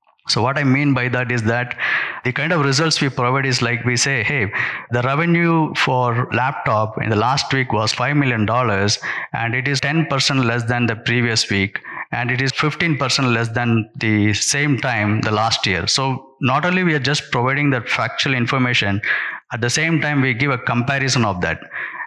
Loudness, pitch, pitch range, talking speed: -18 LUFS, 125 Hz, 115-140 Hz, 195 wpm